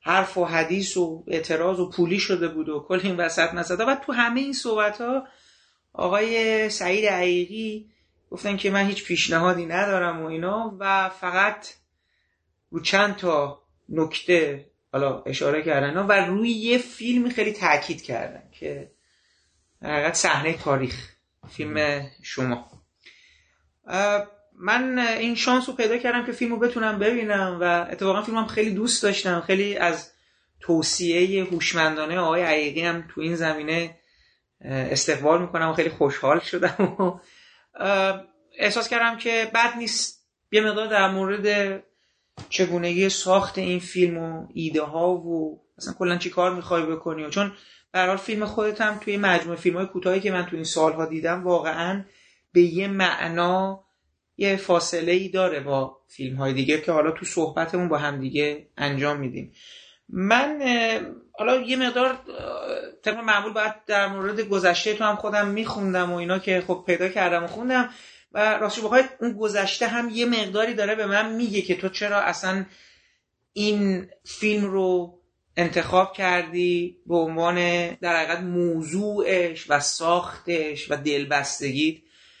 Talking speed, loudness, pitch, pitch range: 145 wpm, -23 LUFS, 185 Hz, 165-210 Hz